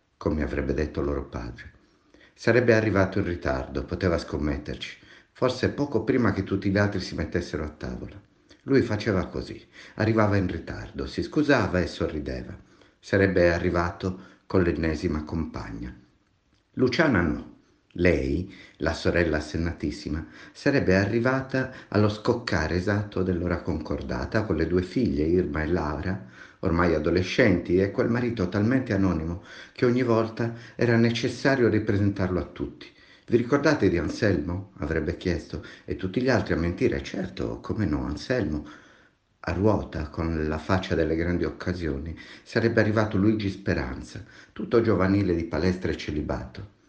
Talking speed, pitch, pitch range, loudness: 135 wpm, 95 Hz, 80-110 Hz, -26 LUFS